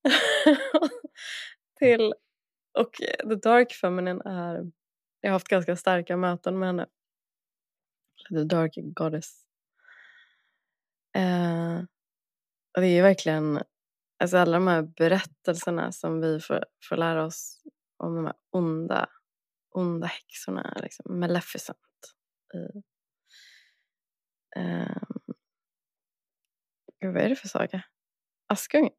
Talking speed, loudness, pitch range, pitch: 105 wpm, -26 LUFS, 170-220 Hz, 180 Hz